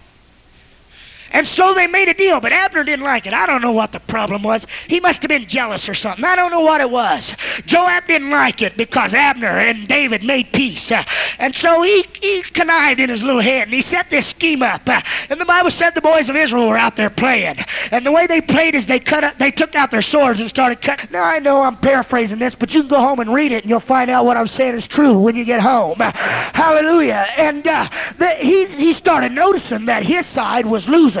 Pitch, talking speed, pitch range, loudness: 275 Hz, 240 wpm, 240-325 Hz, -14 LUFS